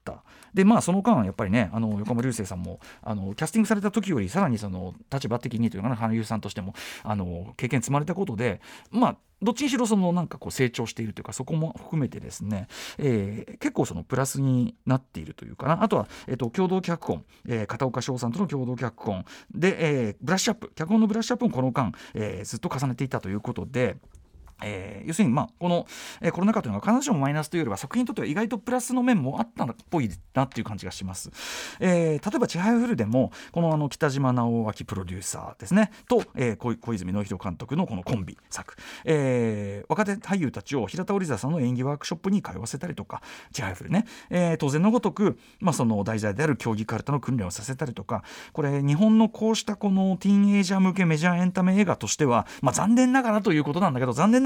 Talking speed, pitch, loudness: 470 characters per minute, 145 Hz, -26 LUFS